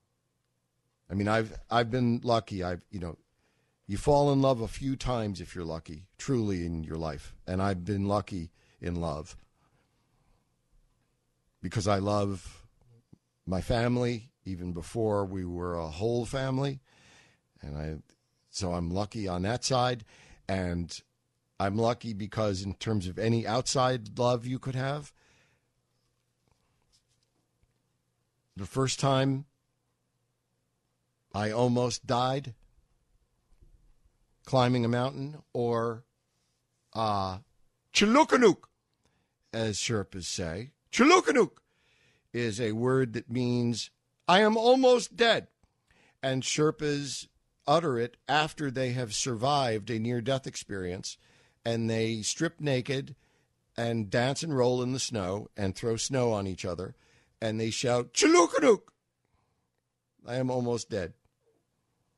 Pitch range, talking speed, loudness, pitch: 95-130 Hz, 120 wpm, -29 LUFS, 115 Hz